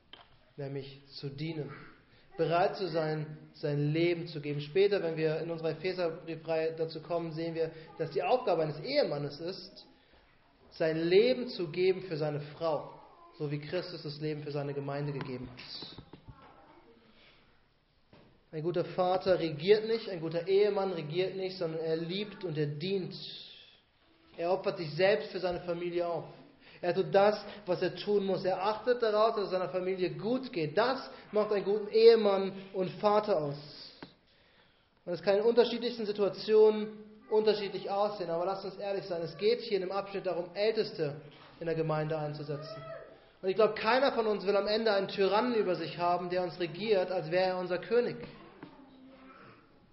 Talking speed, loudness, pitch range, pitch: 165 wpm, -32 LUFS, 160-205 Hz, 180 Hz